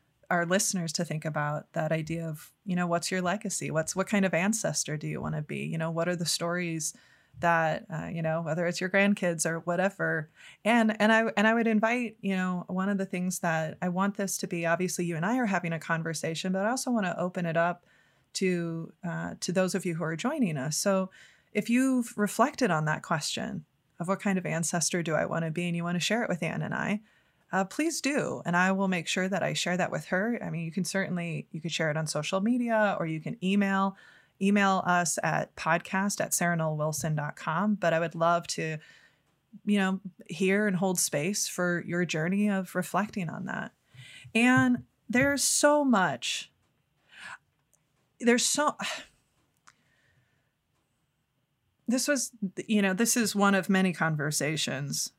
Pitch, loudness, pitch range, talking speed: 180 Hz, -28 LUFS, 165-205 Hz, 195 wpm